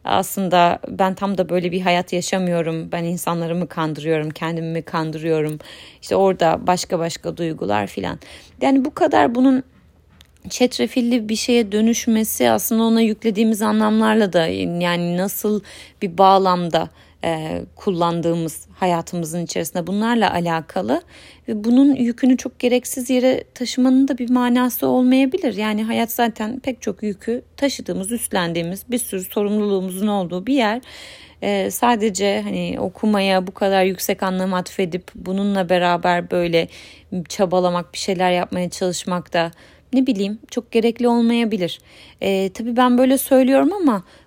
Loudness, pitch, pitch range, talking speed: -19 LUFS, 195 Hz, 175-235 Hz, 130 wpm